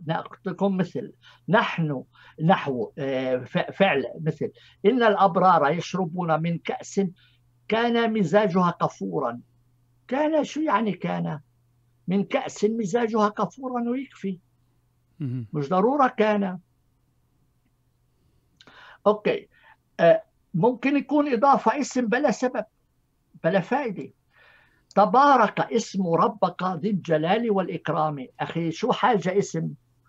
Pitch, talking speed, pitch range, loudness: 185 Hz, 90 wpm, 140-220 Hz, -24 LUFS